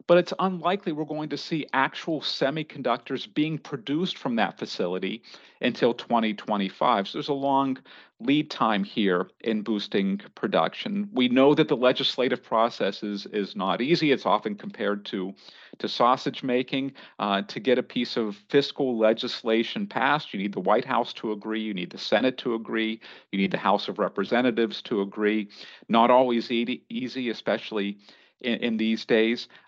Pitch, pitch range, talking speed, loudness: 125 Hz, 110-145 Hz, 165 wpm, -26 LUFS